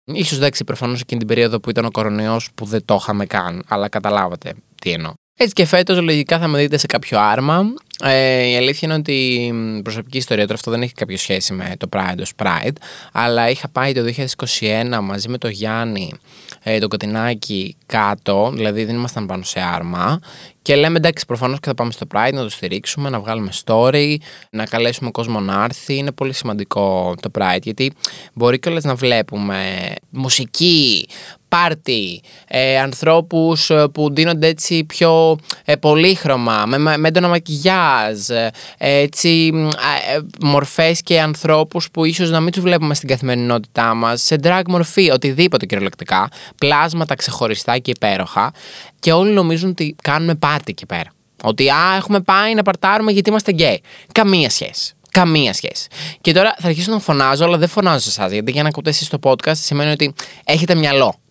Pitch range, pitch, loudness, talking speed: 110-160 Hz, 135 Hz, -16 LUFS, 175 wpm